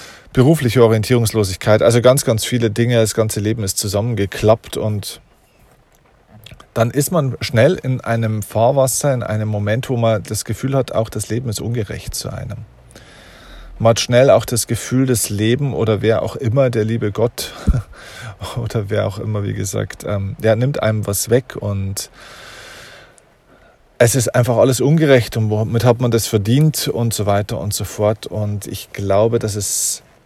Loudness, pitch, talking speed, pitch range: -17 LUFS, 115 Hz, 165 wpm, 105-125 Hz